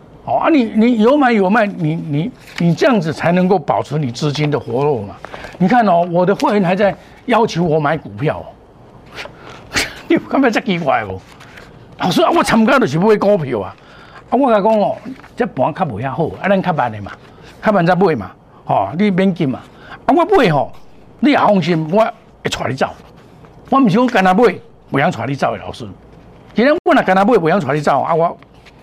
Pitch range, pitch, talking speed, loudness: 175-245 Hz, 205 Hz, 275 characters per minute, -15 LUFS